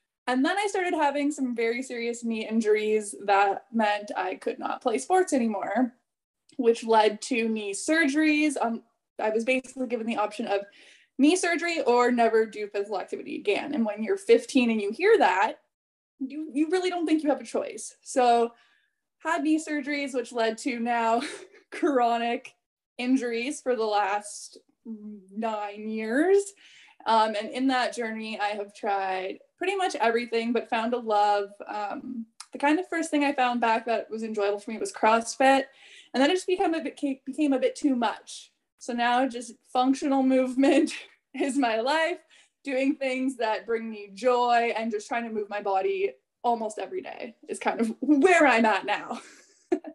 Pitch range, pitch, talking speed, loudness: 220-295 Hz, 245 Hz, 175 wpm, -26 LUFS